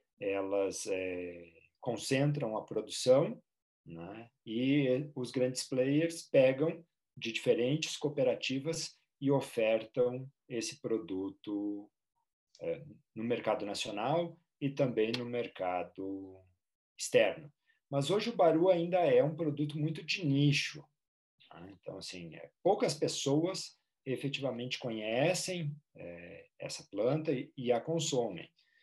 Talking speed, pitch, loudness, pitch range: 110 wpm, 135 Hz, -33 LUFS, 110-160 Hz